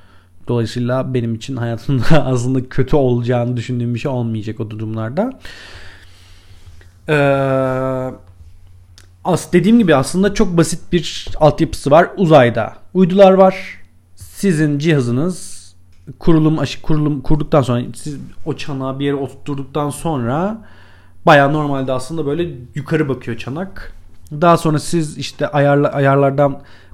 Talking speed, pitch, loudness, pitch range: 115 wpm, 135 Hz, -16 LUFS, 110-155 Hz